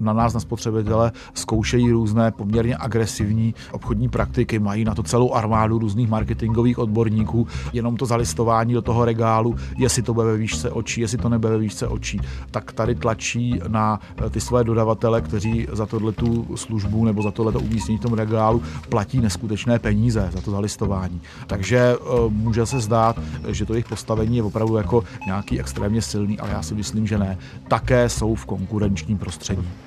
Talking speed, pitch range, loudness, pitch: 170 wpm, 105-115 Hz, -22 LUFS, 110 Hz